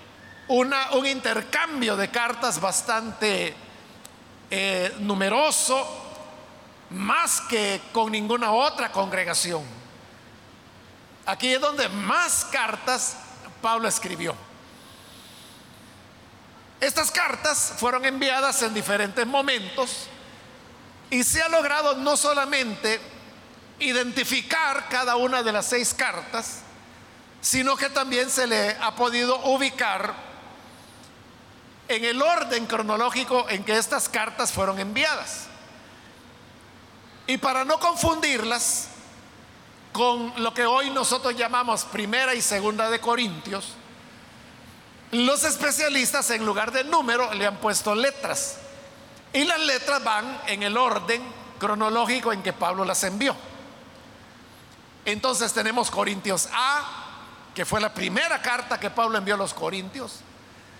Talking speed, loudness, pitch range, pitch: 110 wpm, -24 LUFS, 210-265 Hz, 240 Hz